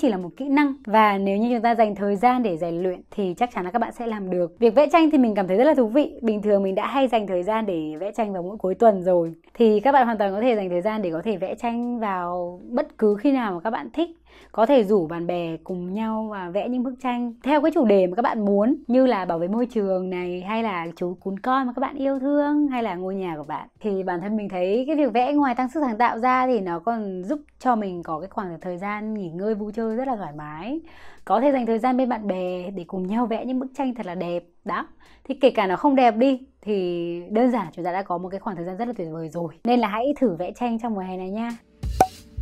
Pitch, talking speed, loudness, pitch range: 220 Hz, 290 wpm, -23 LUFS, 185-250 Hz